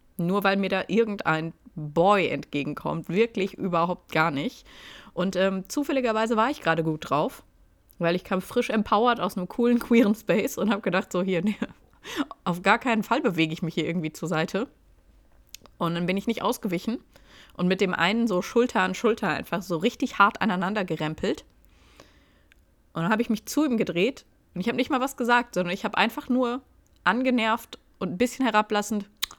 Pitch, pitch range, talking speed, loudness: 200 Hz, 175-235 Hz, 185 wpm, -25 LUFS